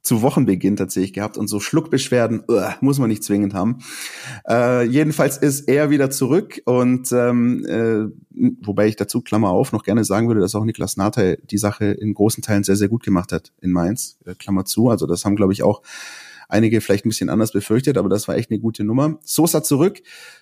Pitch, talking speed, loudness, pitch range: 110 Hz, 210 wpm, -19 LUFS, 100-125 Hz